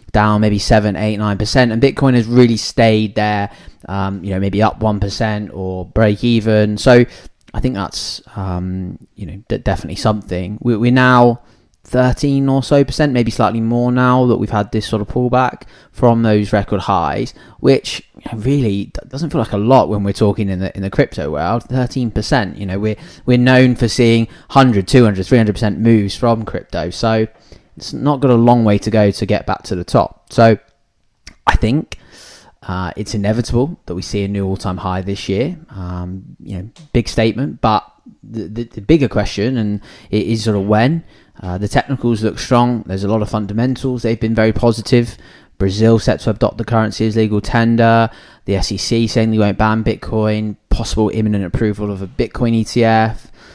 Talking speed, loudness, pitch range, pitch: 185 wpm, -15 LUFS, 100-120 Hz, 110 Hz